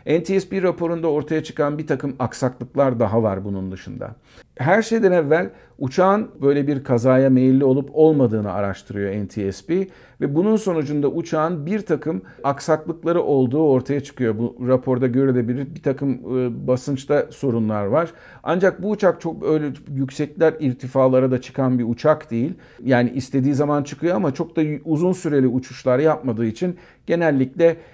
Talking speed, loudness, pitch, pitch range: 140 wpm, -20 LUFS, 140 Hz, 125-160 Hz